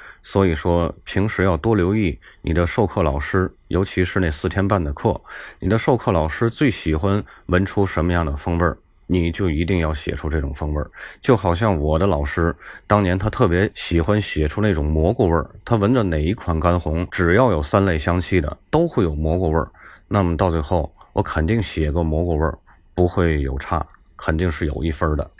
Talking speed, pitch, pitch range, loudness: 295 characters per minute, 85 Hz, 80-100 Hz, -20 LUFS